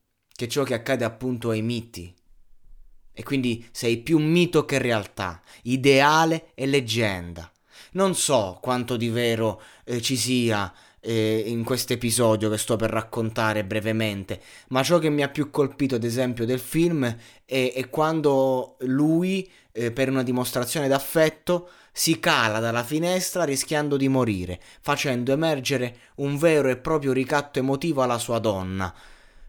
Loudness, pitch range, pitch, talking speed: -24 LUFS, 115-145 Hz, 125 Hz, 145 wpm